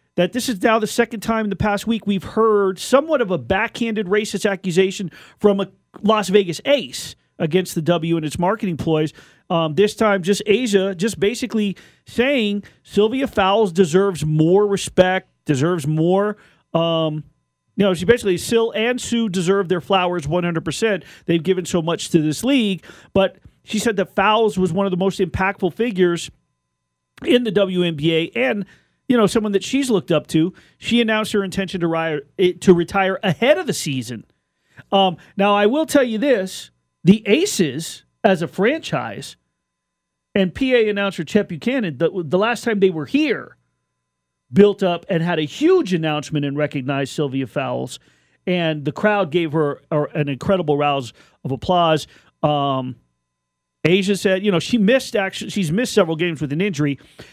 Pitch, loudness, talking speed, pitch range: 190 Hz, -19 LUFS, 170 wpm, 160-210 Hz